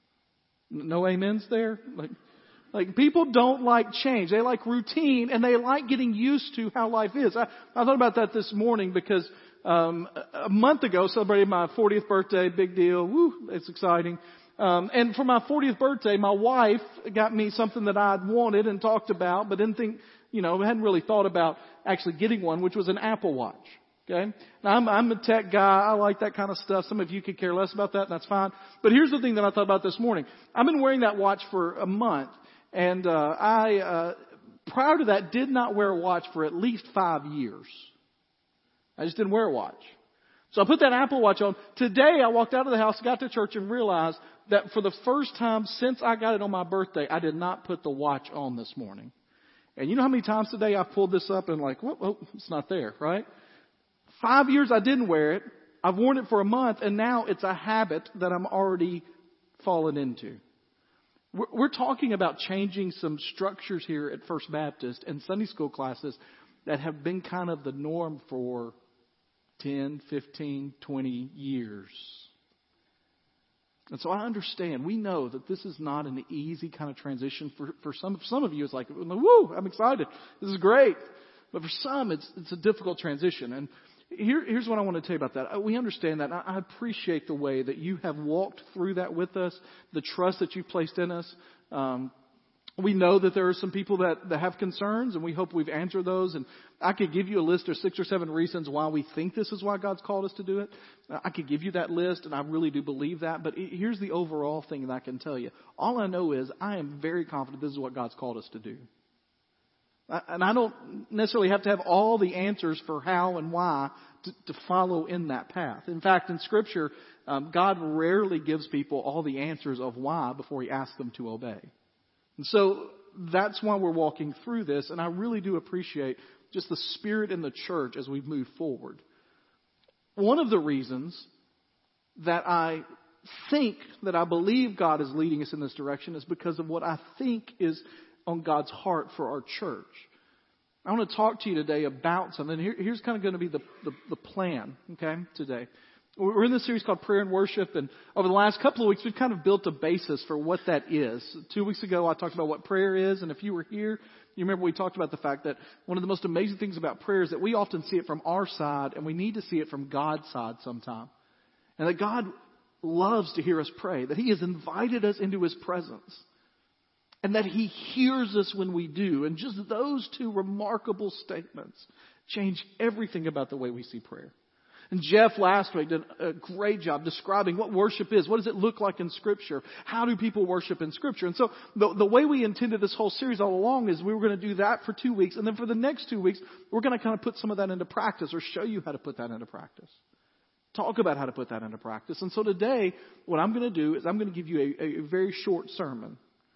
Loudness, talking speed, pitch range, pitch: -28 LUFS, 220 wpm, 160-215 Hz, 190 Hz